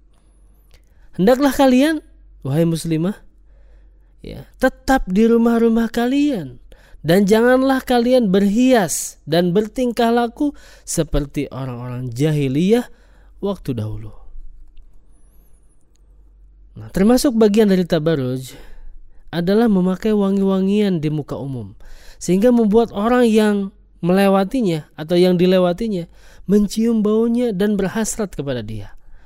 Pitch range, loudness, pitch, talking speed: 145-230 Hz, -17 LUFS, 195 Hz, 95 wpm